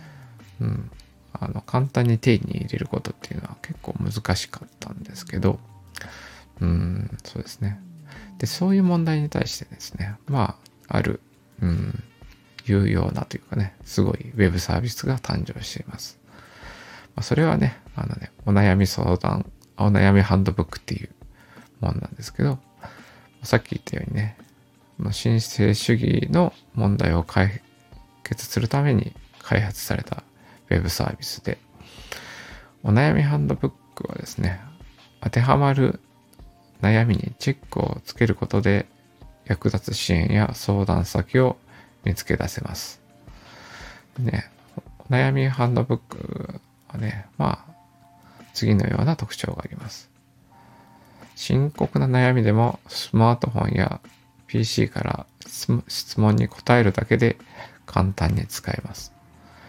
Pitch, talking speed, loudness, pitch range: 115 Hz, 270 characters per minute, -23 LUFS, 100-130 Hz